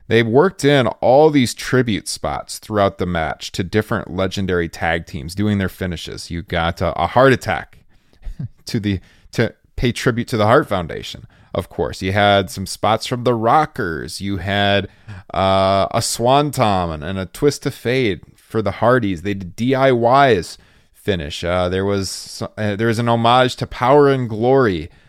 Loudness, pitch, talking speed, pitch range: -18 LUFS, 105 Hz, 175 wpm, 95-120 Hz